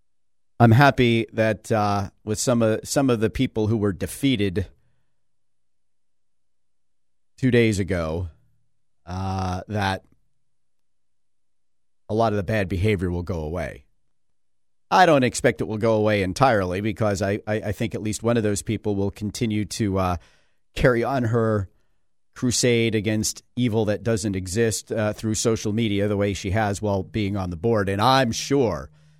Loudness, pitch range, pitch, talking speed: -22 LUFS, 90-115 Hz, 105 Hz, 155 wpm